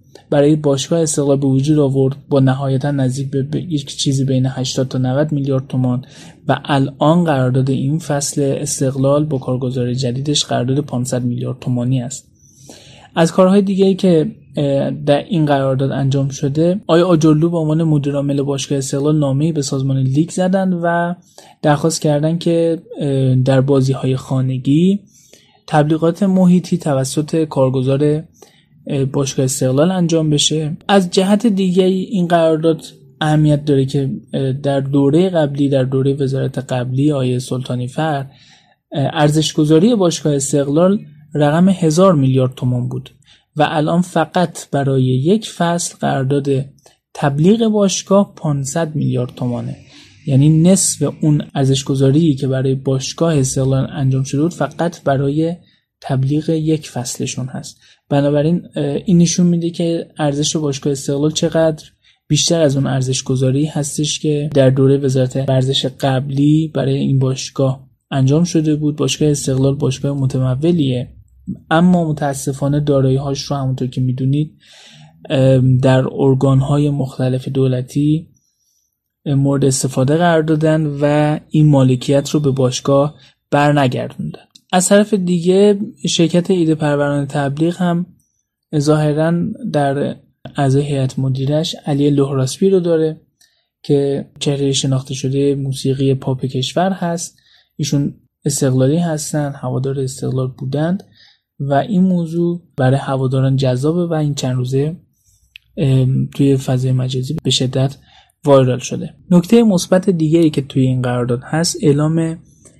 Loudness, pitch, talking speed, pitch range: -16 LUFS, 145 Hz, 125 wpm, 135-160 Hz